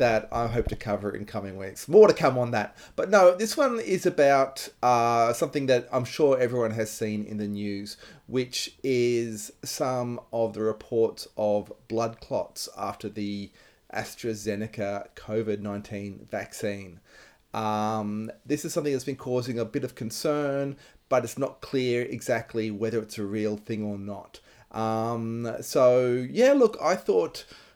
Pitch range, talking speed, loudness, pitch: 105-130 Hz, 160 wpm, -27 LUFS, 115 Hz